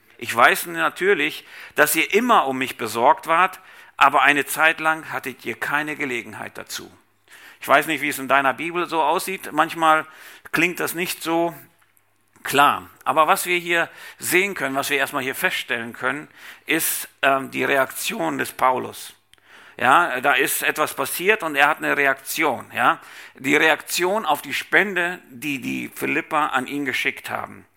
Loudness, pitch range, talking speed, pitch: -20 LUFS, 135-175 Hz, 165 wpm, 155 Hz